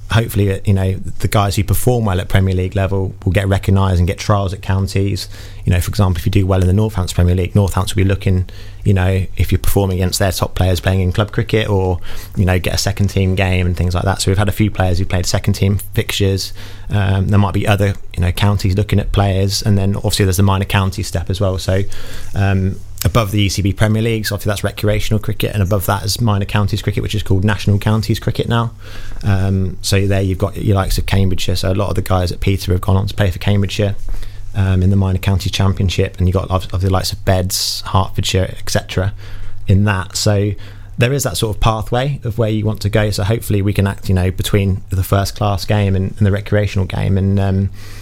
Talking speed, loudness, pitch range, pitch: 240 wpm, -16 LUFS, 95-105 Hz, 100 Hz